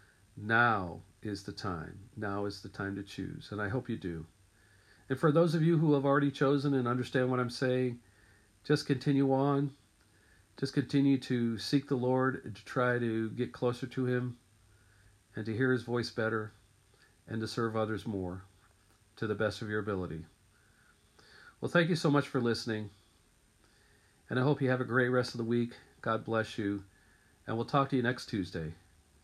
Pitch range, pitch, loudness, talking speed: 100-130 Hz, 110 Hz, -32 LUFS, 185 wpm